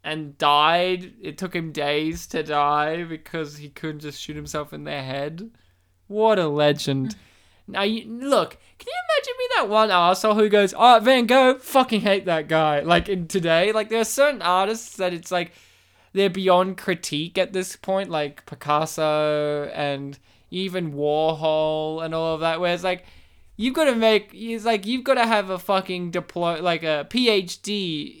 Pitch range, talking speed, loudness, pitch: 150-210 Hz, 175 wpm, -22 LUFS, 175 Hz